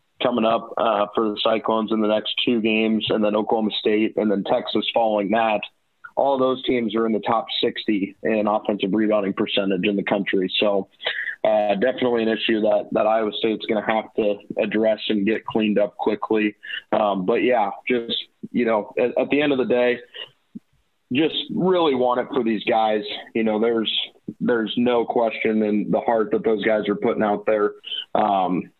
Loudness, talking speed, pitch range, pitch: -21 LUFS, 190 wpm, 105-115 Hz, 110 Hz